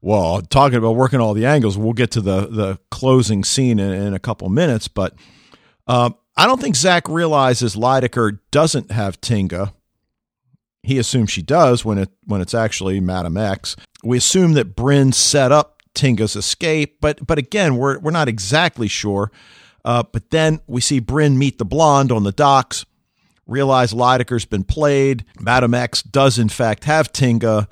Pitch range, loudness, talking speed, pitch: 105-140 Hz, -16 LUFS, 175 wpm, 120 Hz